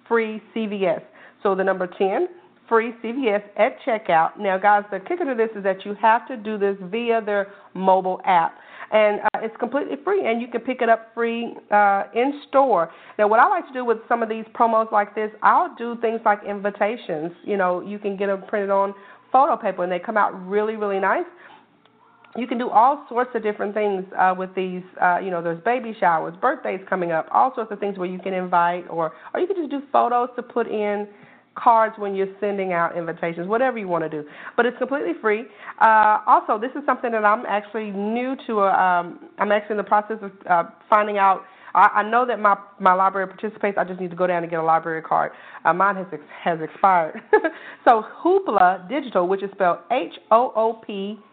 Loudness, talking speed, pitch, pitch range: -21 LUFS, 215 wpm, 210 Hz, 190-235 Hz